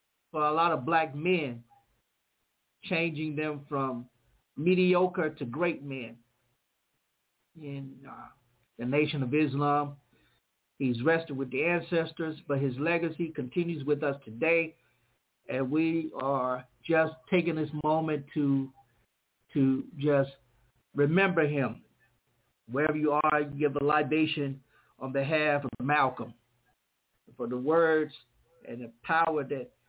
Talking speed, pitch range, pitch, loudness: 120 wpm, 130-160 Hz, 145 Hz, -29 LUFS